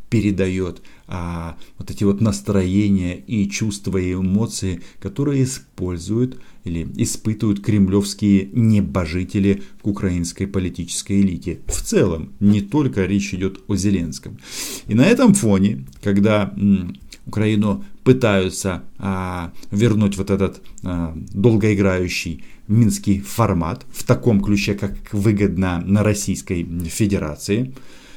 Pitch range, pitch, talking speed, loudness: 90-105 Hz, 100 Hz, 110 wpm, -20 LUFS